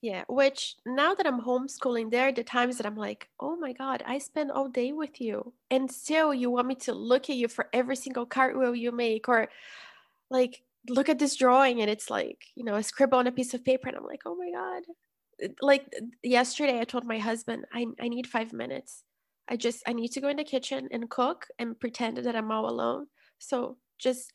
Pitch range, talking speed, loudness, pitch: 240-275 Hz, 225 wpm, -29 LUFS, 255 Hz